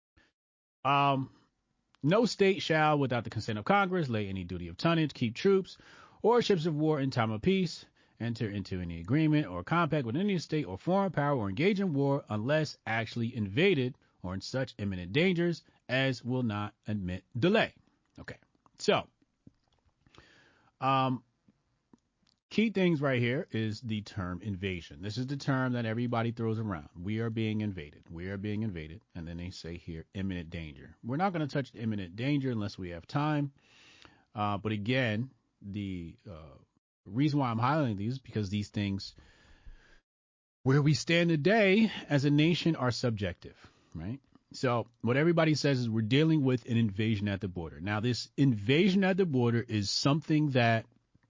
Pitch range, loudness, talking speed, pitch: 105-145 Hz, -31 LUFS, 170 wpm, 120 Hz